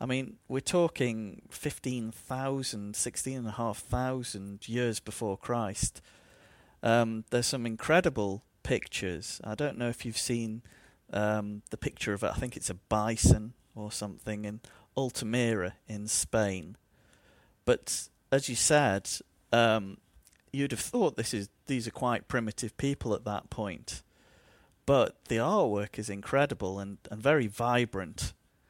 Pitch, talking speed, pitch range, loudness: 115 Hz, 140 wpm, 105-125 Hz, -31 LUFS